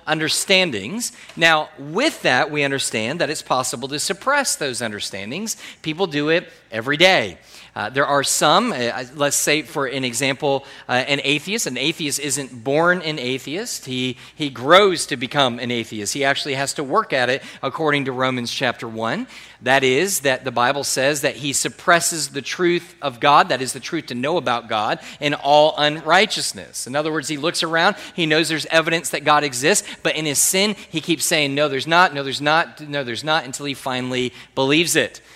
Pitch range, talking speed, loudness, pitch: 130-165 Hz, 195 wpm, -19 LUFS, 145 Hz